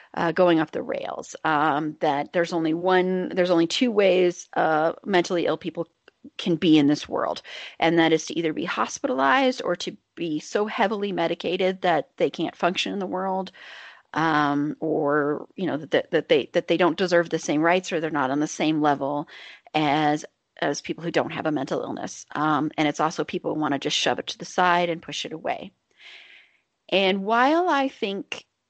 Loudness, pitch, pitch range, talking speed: -24 LUFS, 170 Hz, 155-185 Hz, 195 wpm